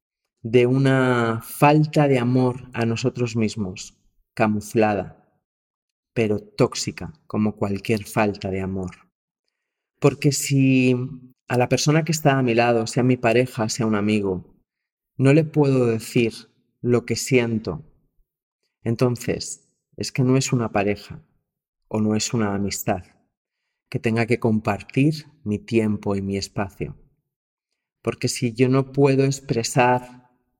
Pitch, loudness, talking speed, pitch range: 120 Hz, -22 LUFS, 130 wpm, 110-130 Hz